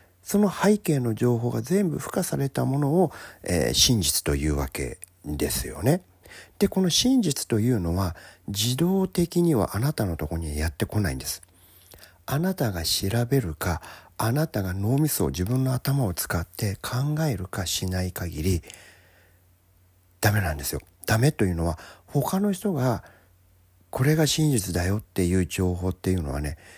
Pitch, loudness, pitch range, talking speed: 100 Hz, -25 LUFS, 90-140 Hz, 300 characters per minute